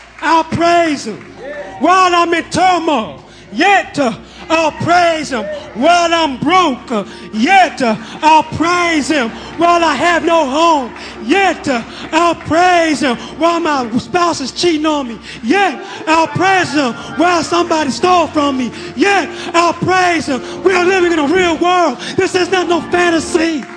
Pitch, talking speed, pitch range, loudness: 325 Hz, 155 wpm, 290-350 Hz, -13 LUFS